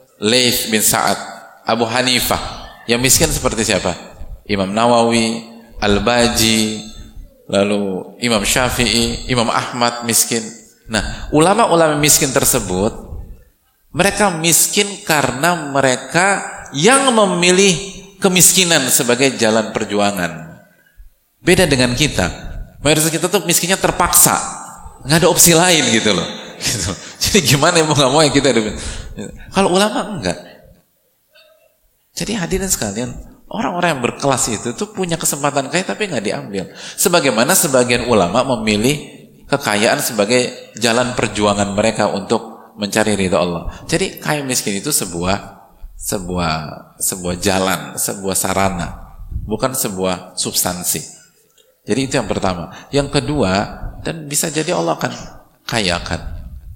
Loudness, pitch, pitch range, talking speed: -15 LUFS, 125 Hz, 105-165 Hz, 115 wpm